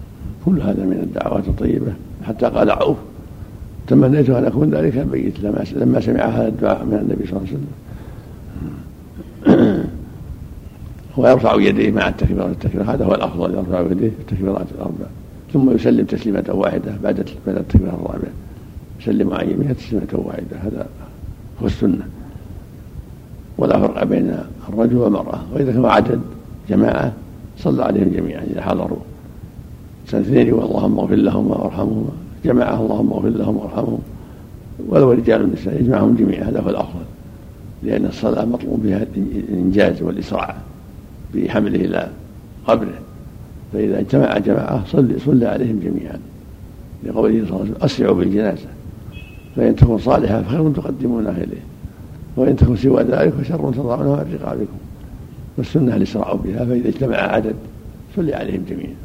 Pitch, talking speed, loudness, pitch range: 105 Hz, 130 wpm, -18 LUFS, 95-115 Hz